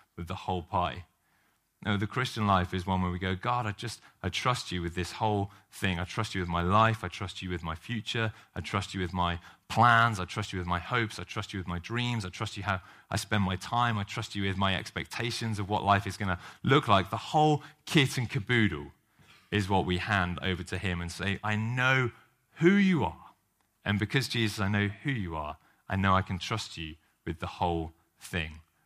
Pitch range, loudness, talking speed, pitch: 90-115 Hz, -30 LUFS, 235 wpm, 100 Hz